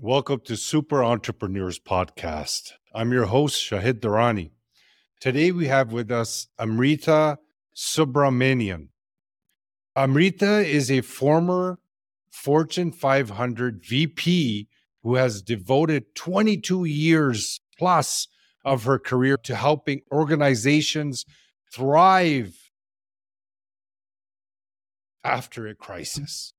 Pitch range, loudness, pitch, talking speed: 110-150 Hz, -22 LUFS, 130 Hz, 90 wpm